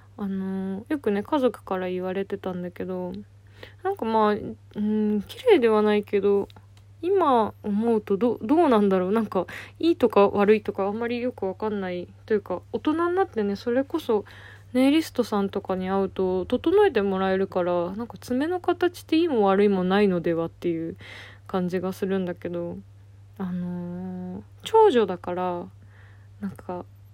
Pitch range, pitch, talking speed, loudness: 175-225 Hz, 195 Hz, 325 characters per minute, -24 LUFS